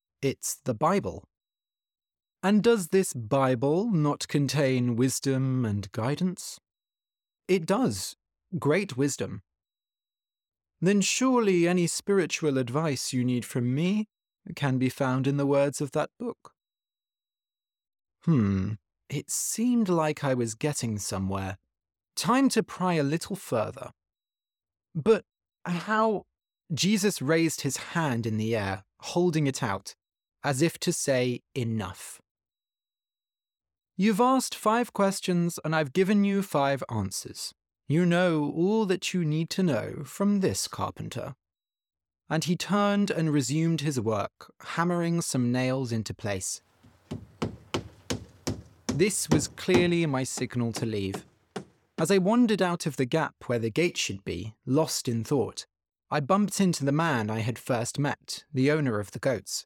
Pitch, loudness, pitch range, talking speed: 140 Hz, -27 LUFS, 110-175 Hz, 135 wpm